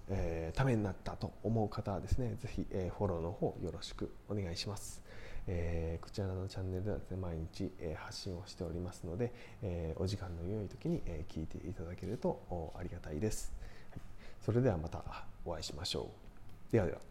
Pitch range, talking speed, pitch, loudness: 85-105 Hz, 380 characters per minute, 95 Hz, -40 LUFS